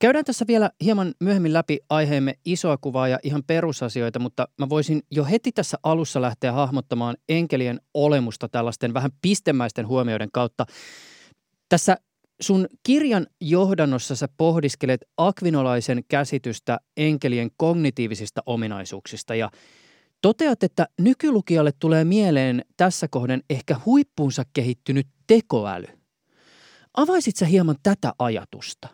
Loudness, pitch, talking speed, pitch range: -22 LUFS, 145 Hz, 115 wpm, 125-180 Hz